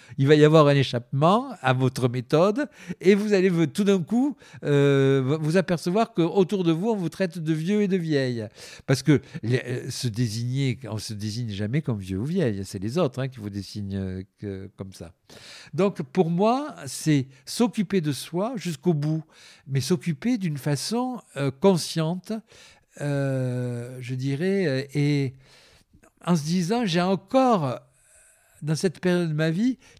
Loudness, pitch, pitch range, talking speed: -24 LUFS, 155 Hz, 130-190 Hz, 165 wpm